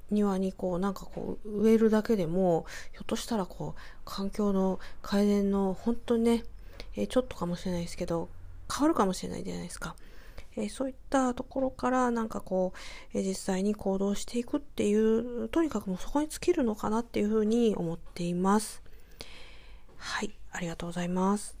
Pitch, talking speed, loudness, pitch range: 205 Hz, 390 characters per minute, -30 LUFS, 185-230 Hz